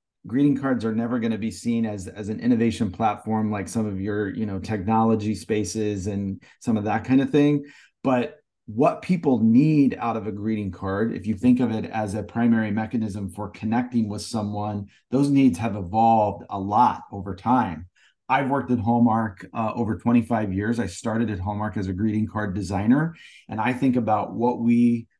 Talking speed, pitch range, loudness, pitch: 195 wpm, 105-120 Hz, -23 LUFS, 110 Hz